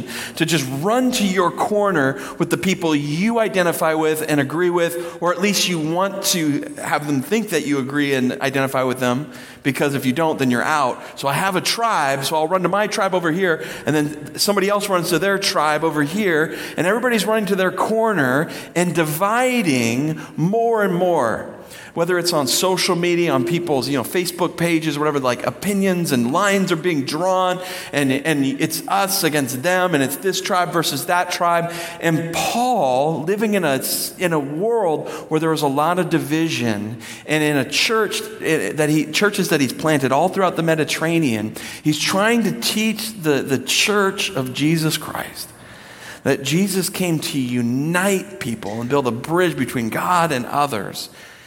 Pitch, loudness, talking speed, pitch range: 165 Hz, -19 LUFS, 185 wpm, 145-185 Hz